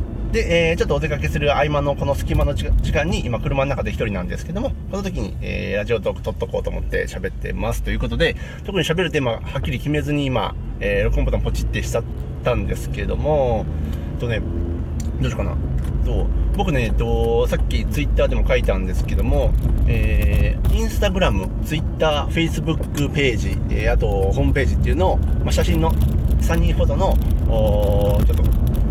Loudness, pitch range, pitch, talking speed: -21 LUFS, 70-120 Hz, 80 Hz, 415 characters per minute